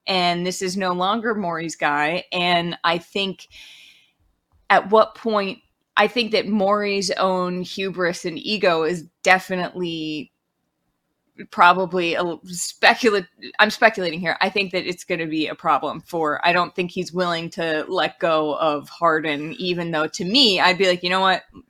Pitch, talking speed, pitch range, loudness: 180 Hz, 165 wpm, 165-195 Hz, -20 LUFS